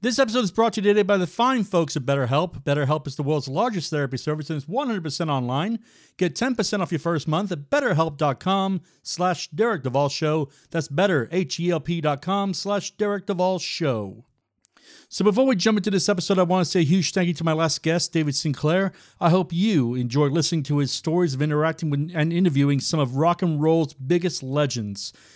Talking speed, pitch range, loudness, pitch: 190 wpm, 145-190 Hz, -23 LUFS, 165 Hz